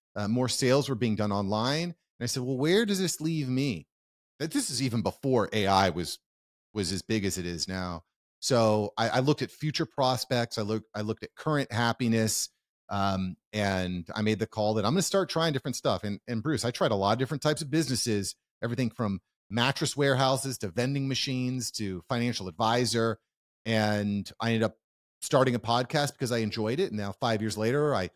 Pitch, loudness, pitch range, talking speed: 115 Hz, -29 LUFS, 105-135 Hz, 205 wpm